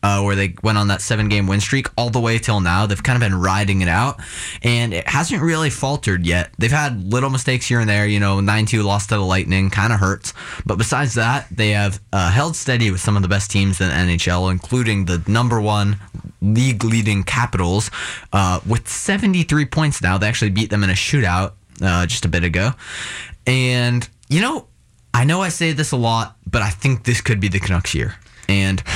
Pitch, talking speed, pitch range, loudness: 105 Hz, 220 wpm, 95-120 Hz, -18 LUFS